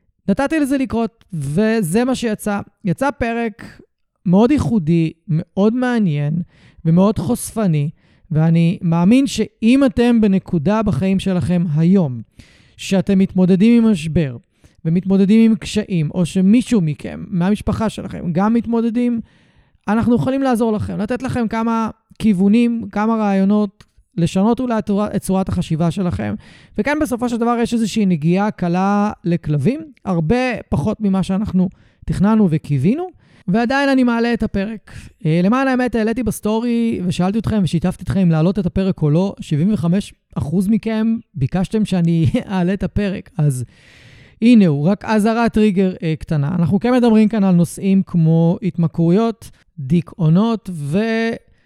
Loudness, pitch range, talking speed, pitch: -17 LUFS, 175-225 Hz, 130 wpm, 200 Hz